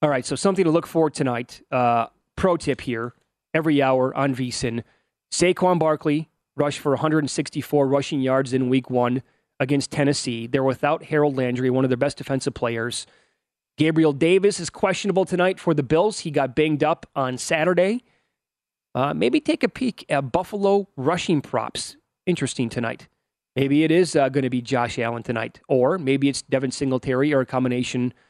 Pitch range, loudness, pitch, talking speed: 130-160 Hz, -22 LUFS, 140 Hz, 175 wpm